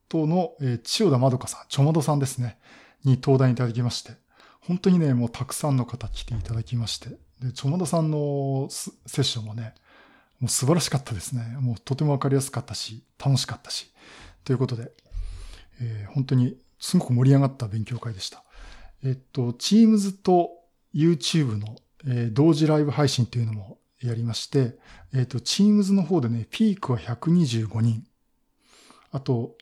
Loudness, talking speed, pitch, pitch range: -24 LUFS, 355 characters per minute, 130 Hz, 115-150 Hz